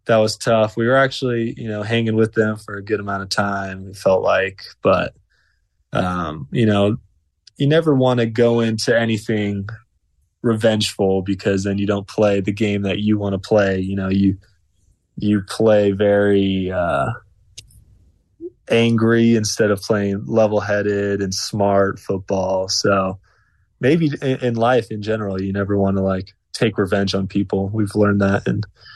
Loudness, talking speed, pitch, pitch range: -19 LUFS, 165 wpm, 100 Hz, 95-110 Hz